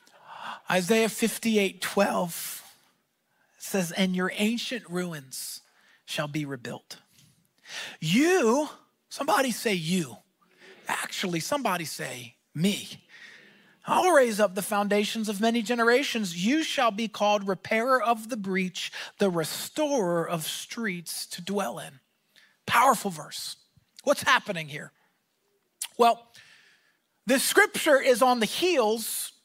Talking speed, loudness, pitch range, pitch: 110 wpm, -26 LUFS, 180-245 Hz, 210 Hz